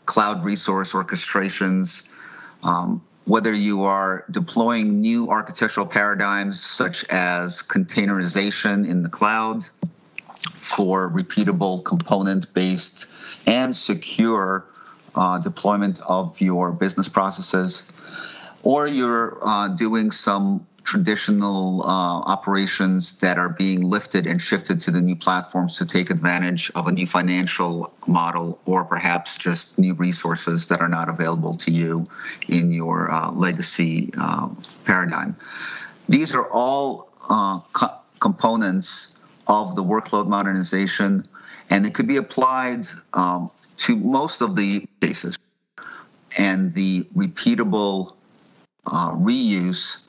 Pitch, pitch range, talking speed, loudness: 95 Hz, 90-105 Hz, 115 wpm, -21 LUFS